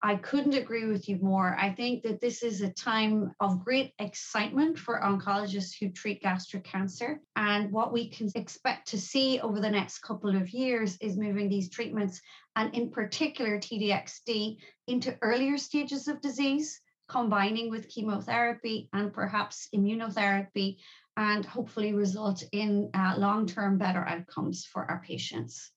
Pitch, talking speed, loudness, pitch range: 210 Hz, 155 wpm, -31 LUFS, 200-235 Hz